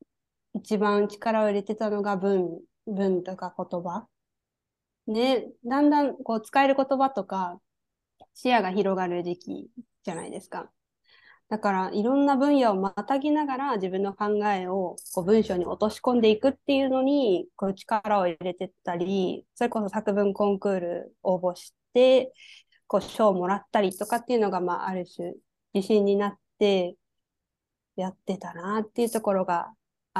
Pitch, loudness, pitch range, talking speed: 205 Hz, -26 LUFS, 185-240 Hz, 300 characters per minute